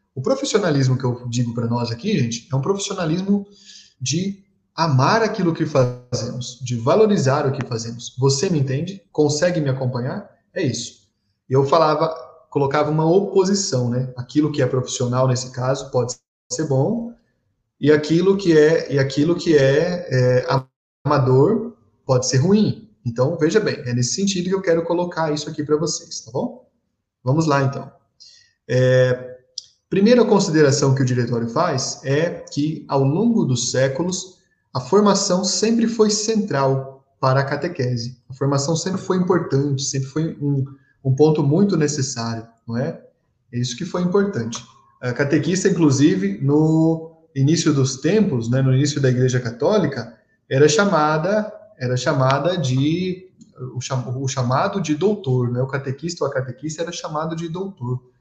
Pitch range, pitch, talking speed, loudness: 125-175 Hz, 140 Hz, 155 wpm, -20 LUFS